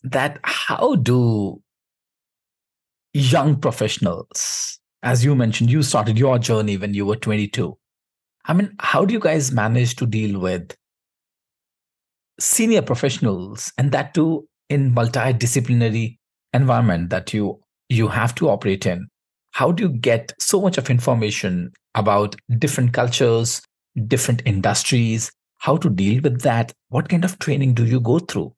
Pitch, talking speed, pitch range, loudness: 120 Hz, 140 wpm, 110-140 Hz, -19 LUFS